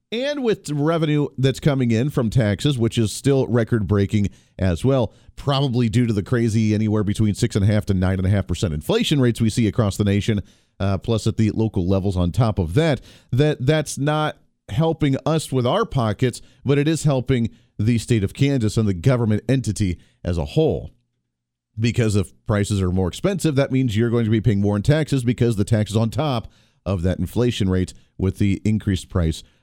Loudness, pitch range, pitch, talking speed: -21 LUFS, 100-135 Hz, 115 Hz, 205 wpm